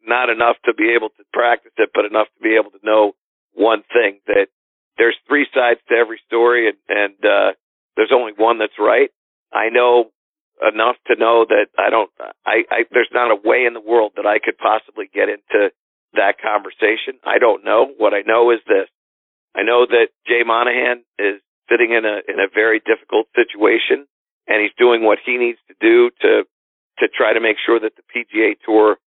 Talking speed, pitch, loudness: 200 wpm, 350 Hz, -16 LUFS